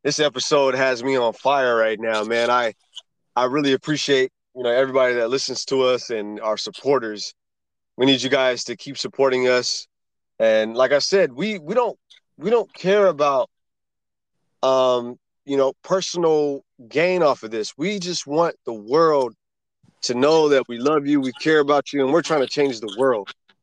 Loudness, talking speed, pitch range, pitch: -20 LUFS, 185 wpm, 125-150 Hz, 135 Hz